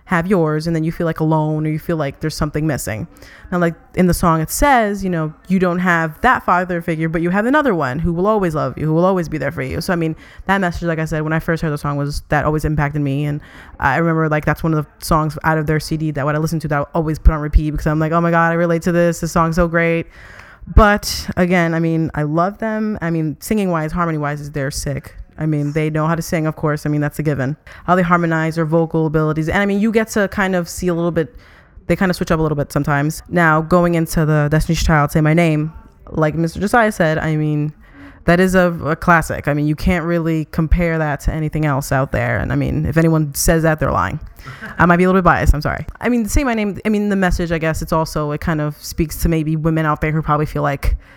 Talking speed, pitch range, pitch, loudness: 280 wpm, 155-175 Hz, 160 Hz, -17 LUFS